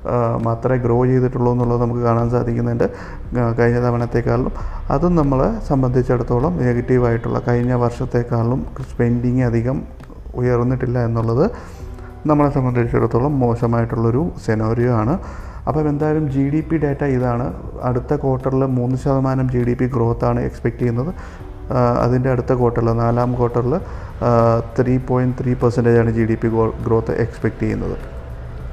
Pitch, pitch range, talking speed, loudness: 120 Hz, 115-130 Hz, 120 wpm, -18 LUFS